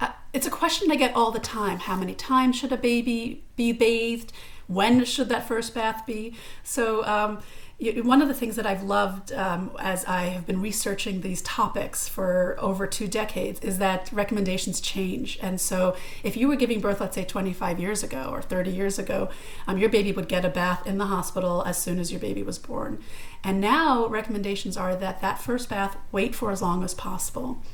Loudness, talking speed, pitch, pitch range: -26 LUFS, 205 wpm, 205 Hz, 190-230 Hz